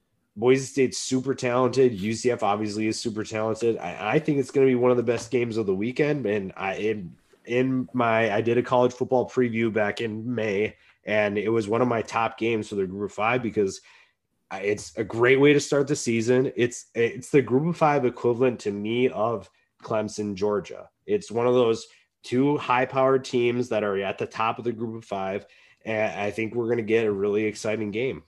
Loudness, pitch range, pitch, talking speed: -25 LUFS, 110-125 Hz, 115 Hz, 215 wpm